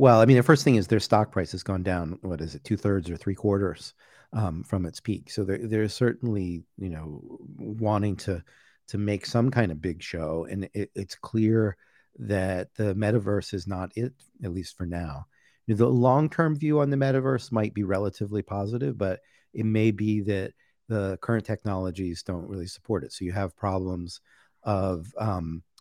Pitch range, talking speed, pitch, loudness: 90-110 Hz, 200 wpm, 100 Hz, -27 LUFS